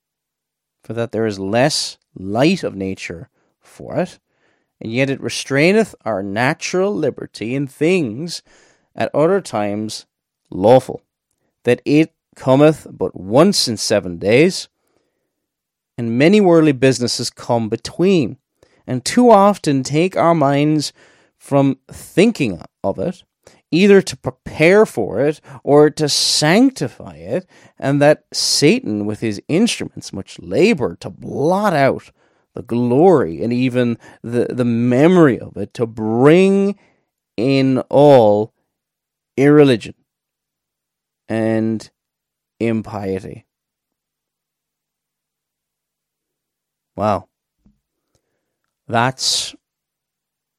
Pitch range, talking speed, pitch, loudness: 110-155 Hz, 100 wpm, 130 Hz, -16 LUFS